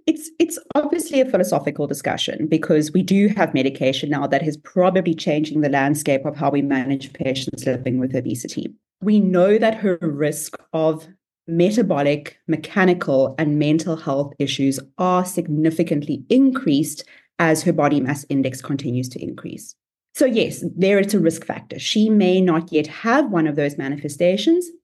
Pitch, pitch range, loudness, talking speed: 160 Hz, 145-190 Hz, -20 LUFS, 155 wpm